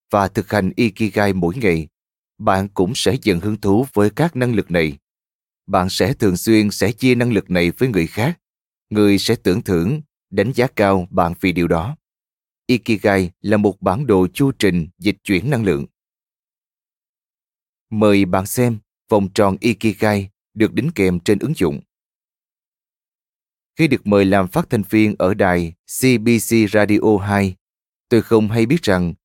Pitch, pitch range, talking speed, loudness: 105 Hz, 95-115 Hz, 165 wpm, -17 LUFS